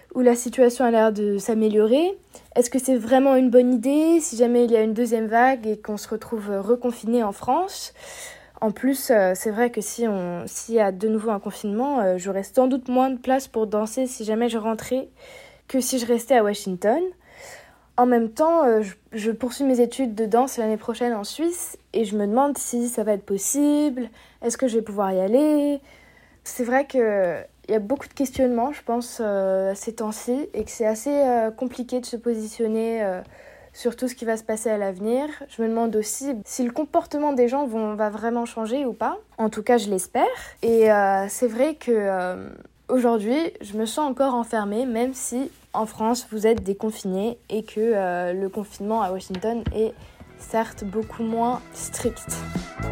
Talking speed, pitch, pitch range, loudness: 200 wpm, 235 Hz, 215-255 Hz, -23 LUFS